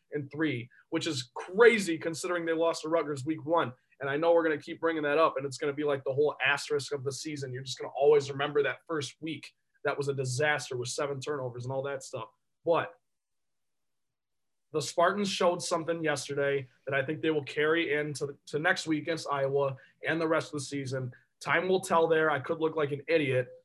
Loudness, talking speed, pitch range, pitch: -30 LUFS, 225 wpm, 140-165 Hz, 150 Hz